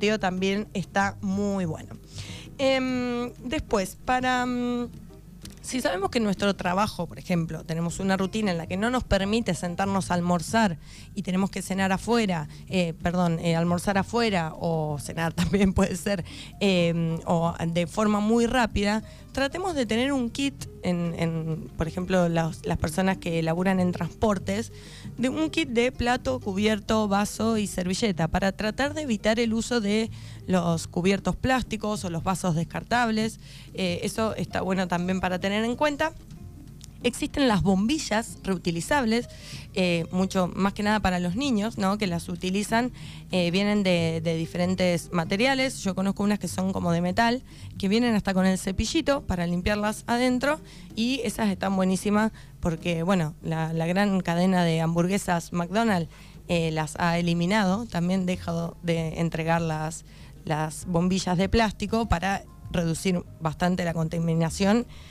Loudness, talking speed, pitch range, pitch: -26 LUFS, 155 wpm, 170-220 Hz, 190 Hz